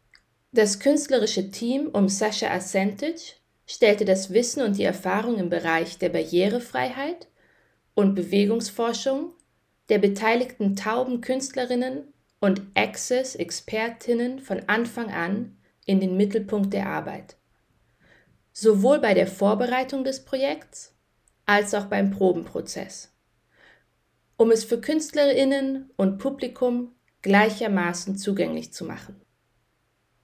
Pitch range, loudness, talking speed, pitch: 195-255 Hz, -24 LUFS, 105 wpm, 220 Hz